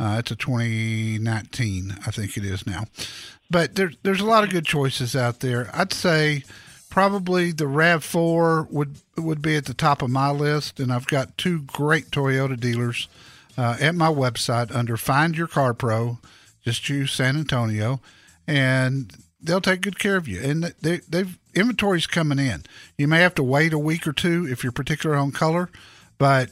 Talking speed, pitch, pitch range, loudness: 185 wpm, 140 Hz, 120-165 Hz, -22 LUFS